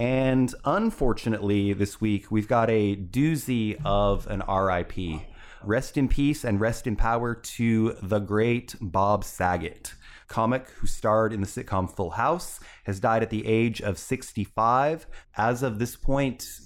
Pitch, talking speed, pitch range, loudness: 110 Hz, 150 wpm, 100-125 Hz, -26 LUFS